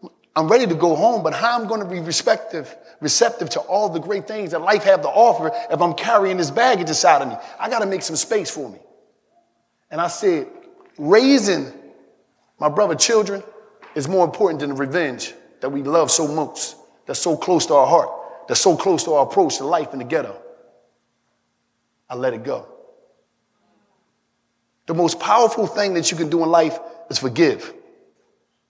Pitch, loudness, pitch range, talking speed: 200 Hz, -19 LUFS, 165-235 Hz, 190 wpm